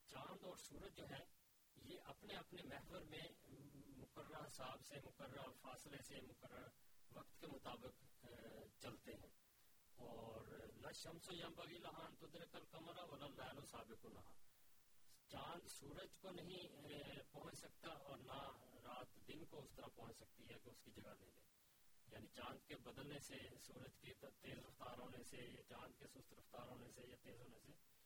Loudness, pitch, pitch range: -59 LUFS, 135 Hz, 120-150 Hz